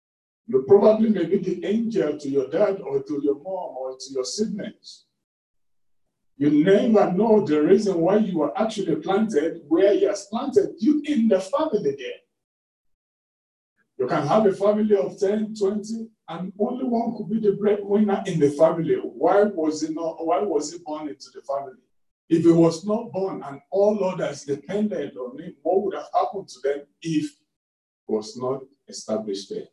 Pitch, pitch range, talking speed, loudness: 190 Hz, 150-210 Hz, 180 wpm, -23 LUFS